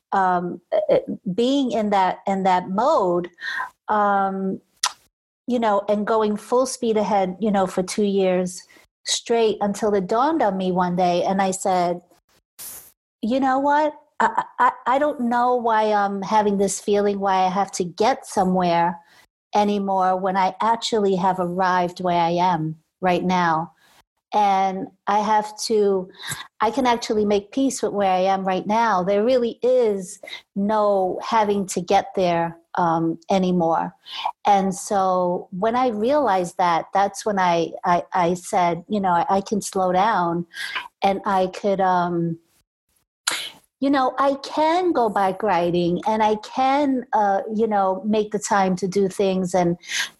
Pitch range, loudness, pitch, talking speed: 185-225 Hz, -21 LUFS, 200 Hz, 155 wpm